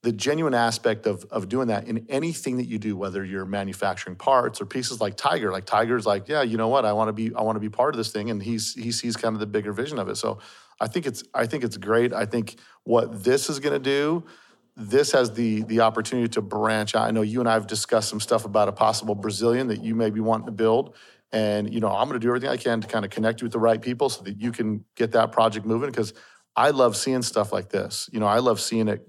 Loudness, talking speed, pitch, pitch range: -24 LUFS, 275 wpm, 115 Hz, 105-120 Hz